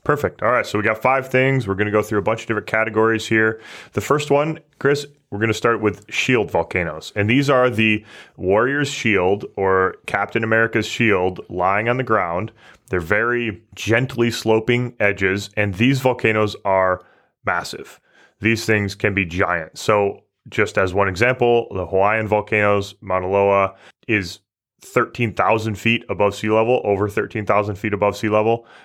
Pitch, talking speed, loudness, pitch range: 110 Hz, 170 wpm, -19 LUFS, 100-120 Hz